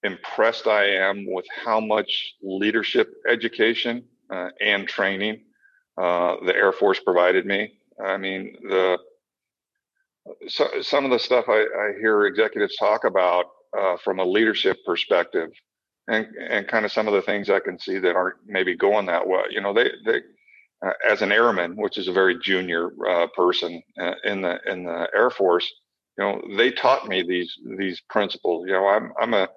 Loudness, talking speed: -22 LUFS, 180 wpm